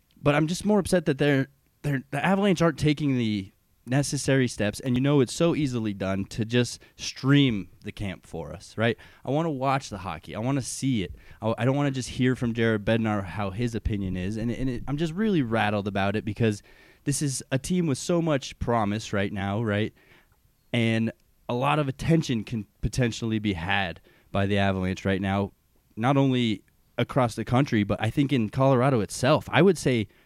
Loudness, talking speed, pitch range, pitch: -26 LUFS, 210 wpm, 105-140 Hz, 120 Hz